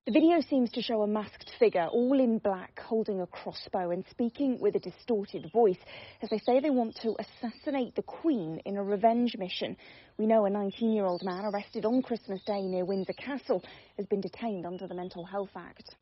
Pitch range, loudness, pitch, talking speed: 190-240 Hz, -31 LUFS, 215 Hz, 205 wpm